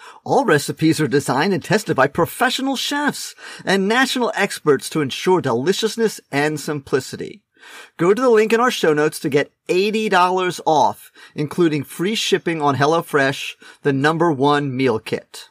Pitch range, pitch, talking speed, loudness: 150-215 Hz, 170 Hz, 150 wpm, -18 LUFS